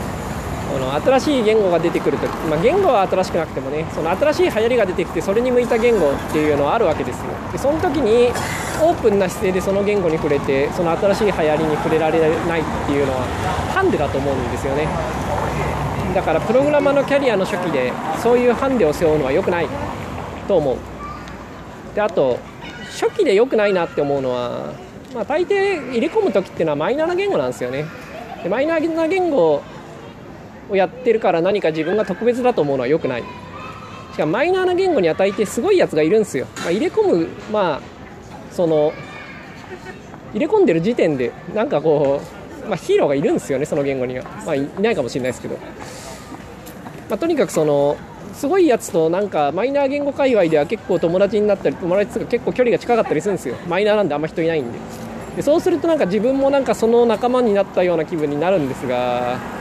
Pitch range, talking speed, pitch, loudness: 160-270 Hz, 425 characters per minute, 205 Hz, -18 LUFS